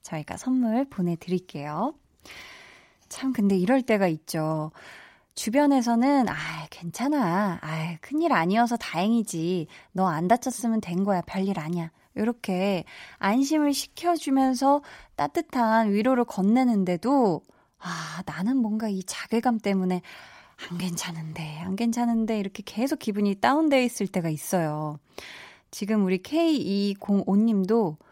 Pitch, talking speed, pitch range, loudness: 205 Hz, 260 characters per minute, 180-250 Hz, -26 LUFS